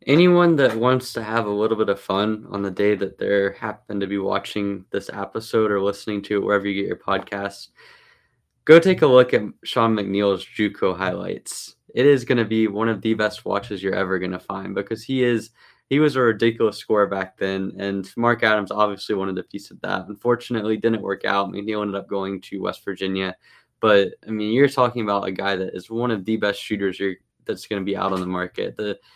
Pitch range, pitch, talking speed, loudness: 100-115 Hz, 105 Hz, 225 wpm, -22 LUFS